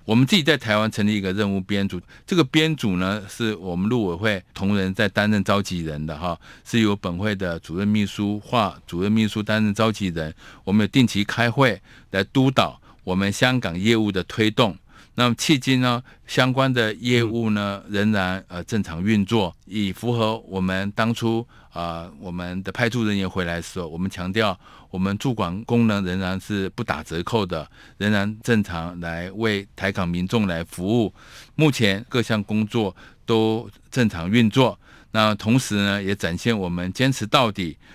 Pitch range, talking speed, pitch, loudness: 95-115 Hz, 265 characters per minute, 105 Hz, -22 LUFS